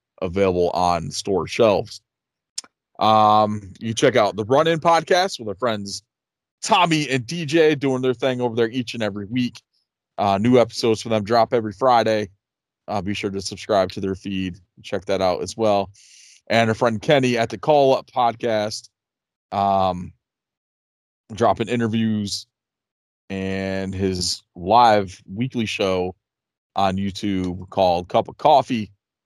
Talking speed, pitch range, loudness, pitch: 150 wpm, 95-120 Hz, -20 LUFS, 105 Hz